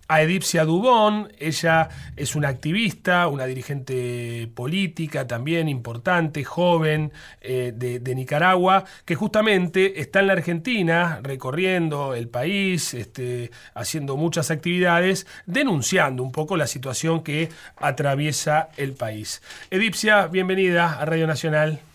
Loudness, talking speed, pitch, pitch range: -22 LUFS, 120 wpm, 160 Hz, 135-180 Hz